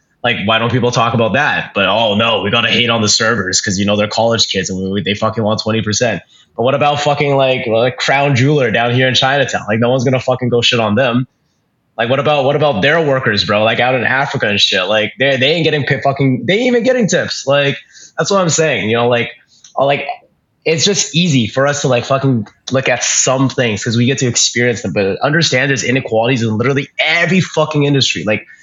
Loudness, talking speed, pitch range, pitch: -13 LUFS, 240 wpm, 110-140 Hz, 130 Hz